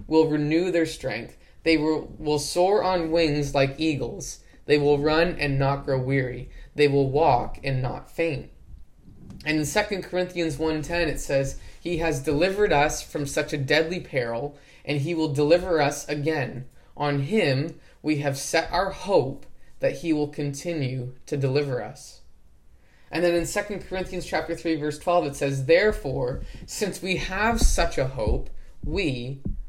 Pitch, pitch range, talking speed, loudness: 150 Hz, 140-165 Hz, 160 wpm, -25 LUFS